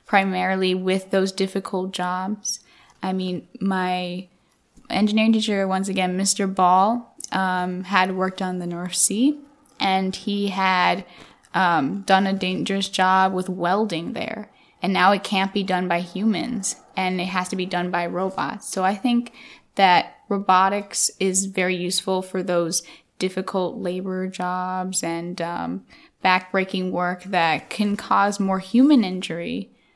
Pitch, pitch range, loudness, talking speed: 190 Hz, 185-200 Hz, -22 LUFS, 140 wpm